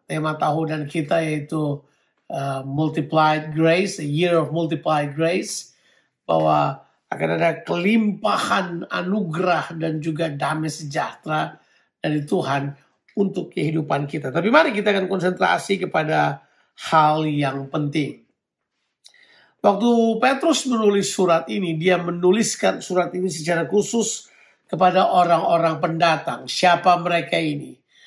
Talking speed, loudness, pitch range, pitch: 115 wpm, -21 LUFS, 155-185 Hz, 165 Hz